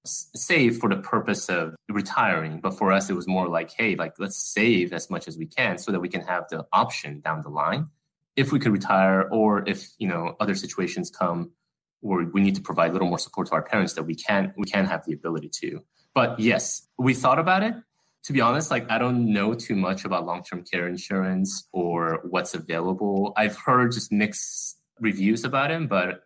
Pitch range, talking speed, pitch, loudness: 90-115 Hz, 215 wpm, 100 Hz, -24 LUFS